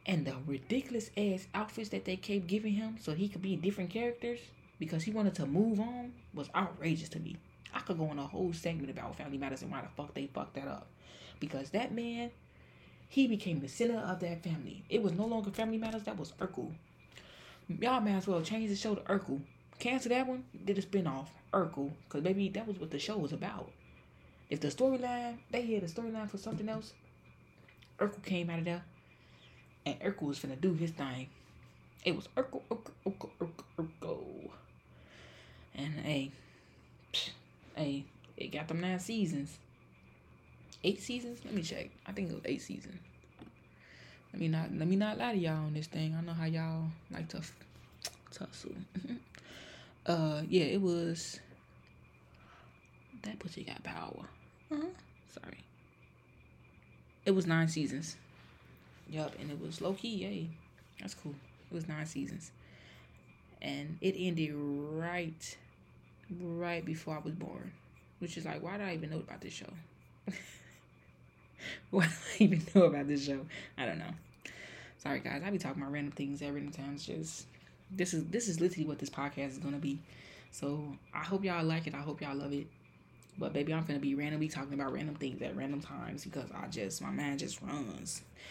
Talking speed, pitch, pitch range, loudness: 180 wpm, 160 Hz, 140-195 Hz, -37 LUFS